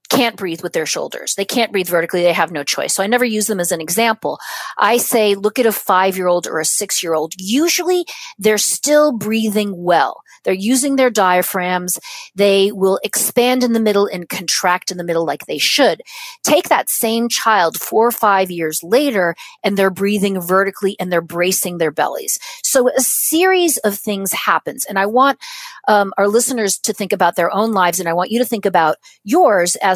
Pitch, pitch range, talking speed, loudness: 205 Hz, 180-245 Hz, 205 wpm, -16 LUFS